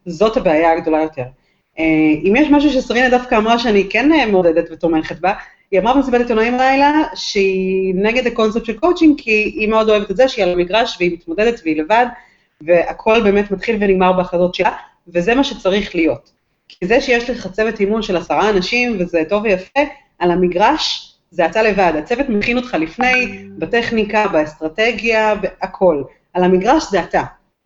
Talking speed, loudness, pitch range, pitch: 165 wpm, -15 LUFS, 180-240 Hz, 210 Hz